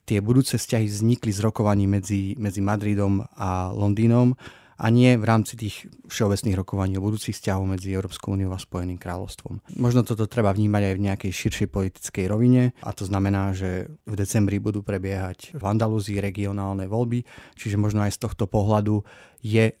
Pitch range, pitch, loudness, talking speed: 100-110 Hz, 105 Hz, -24 LUFS, 170 wpm